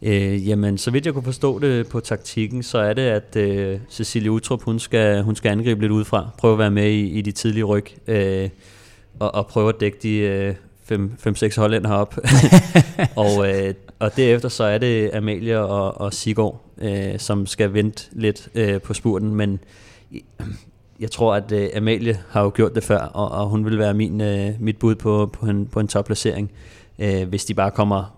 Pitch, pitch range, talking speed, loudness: 105 Hz, 100-110 Hz, 195 wpm, -20 LUFS